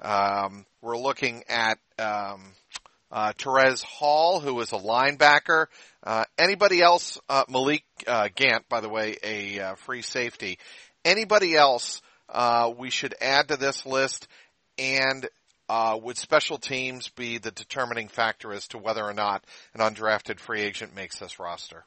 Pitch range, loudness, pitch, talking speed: 110-135 Hz, -24 LUFS, 120 Hz, 155 wpm